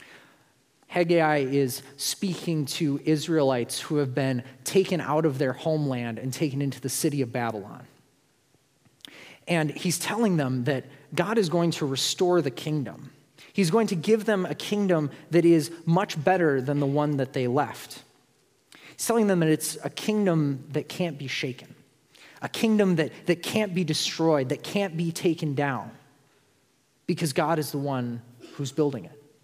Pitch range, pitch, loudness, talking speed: 140-175 Hz, 150 Hz, -26 LUFS, 165 wpm